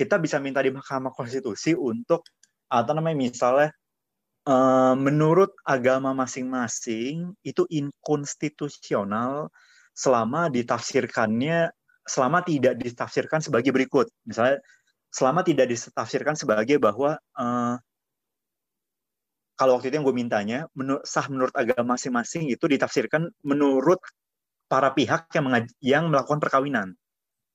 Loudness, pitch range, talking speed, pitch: -24 LUFS, 130-155 Hz, 105 wpm, 135 Hz